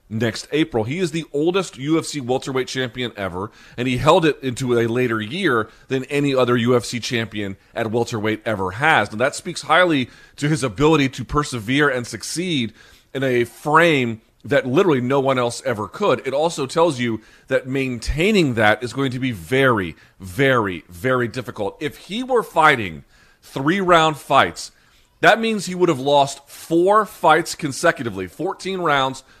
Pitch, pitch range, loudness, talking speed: 130 Hz, 120-155 Hz, -19 LUFS, 165 wpm